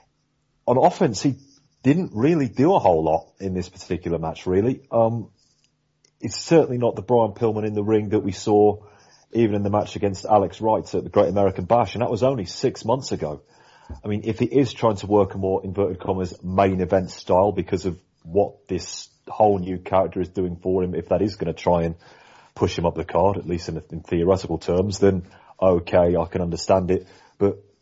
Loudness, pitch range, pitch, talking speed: -22 LUFS, 90-115 Hz, 100 Hz, 205 wpm